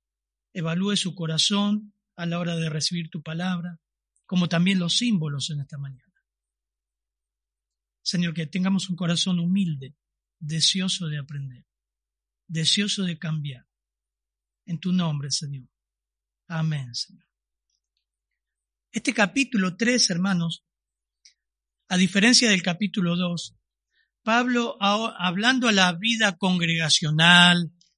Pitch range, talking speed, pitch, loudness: 130-185 Hz, 105 wpm, 170 Hz, -23 LUFS